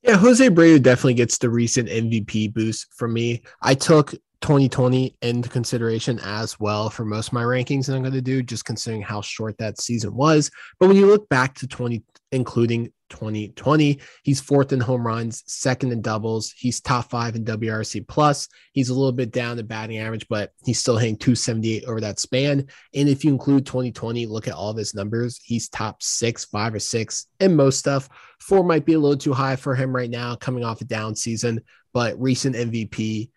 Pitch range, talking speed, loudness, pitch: 110-135 Hz, 205 wpm, -21 LUFS, 120 Hz